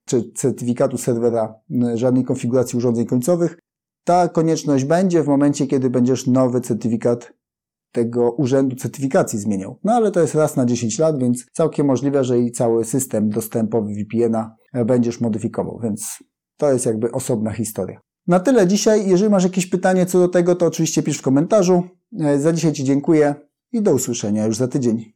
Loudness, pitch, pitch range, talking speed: -19 LUFS, 130 Hz, 120-160 Hz, 165 wpm